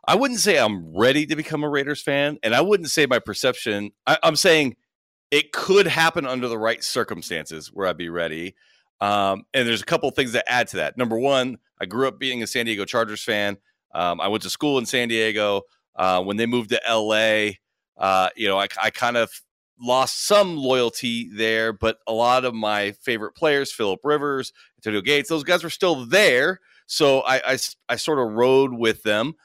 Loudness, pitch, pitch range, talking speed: -21 LUFS, 120 Hz, 105-145 Hz, 210 wpm